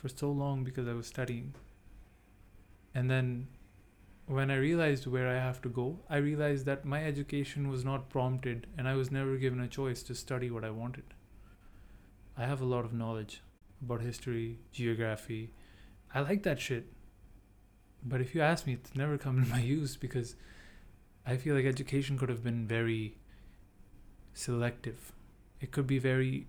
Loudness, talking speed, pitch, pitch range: -35 LUFS, 170 wpm, 125 Hz, 105-135 Hz